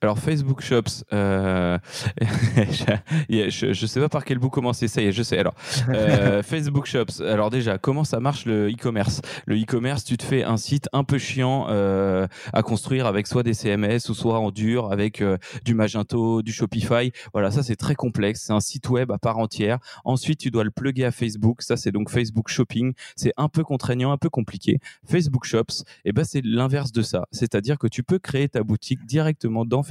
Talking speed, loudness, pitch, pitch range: 210 wpm, -23 LUFS, 120 Hz, 110-135 Hz